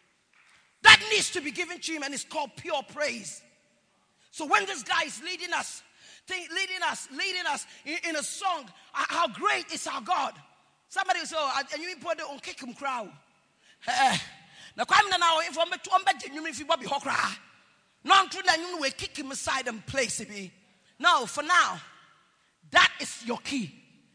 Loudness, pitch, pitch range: -26 LUFS, 325 Hz, 280-360 Hz